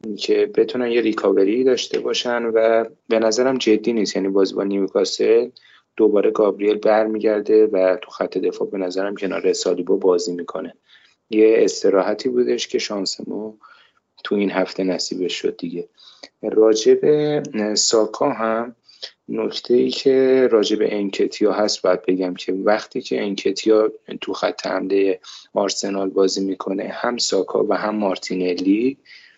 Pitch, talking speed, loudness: 110 Hz, 135 wpm, -19 LUFS